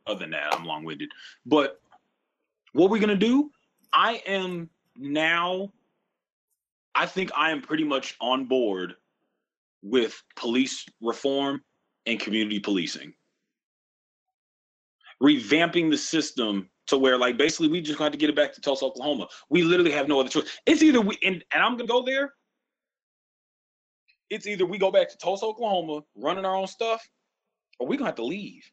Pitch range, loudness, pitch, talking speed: 140-225 Hz, -25 LUFS, 175 Hz, 160 wpm